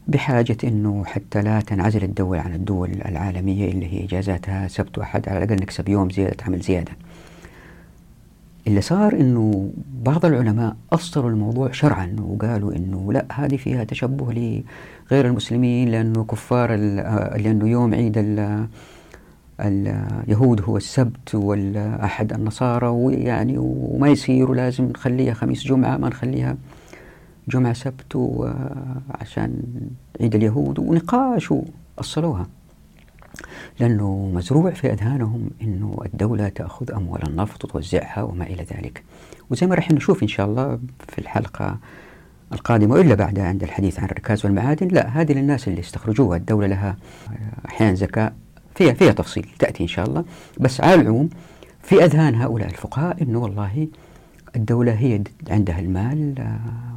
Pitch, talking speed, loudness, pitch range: 110 Hz, 130 wpm, -21 LUFS, 100-130 Hz